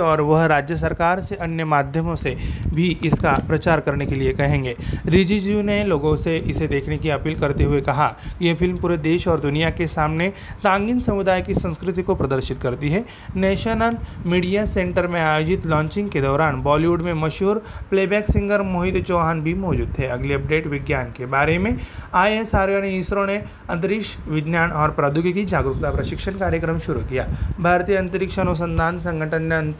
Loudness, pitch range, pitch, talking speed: -21 LUFS, 150-190 Hz, 165 Hz, 175 wpm